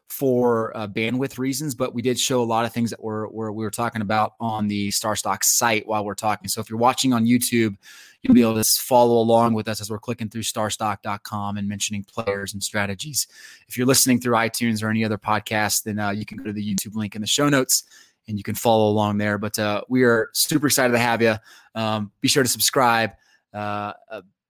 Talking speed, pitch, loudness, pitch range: 230 wpm, 110 Hz, -21 LUFS, 105-120 Hz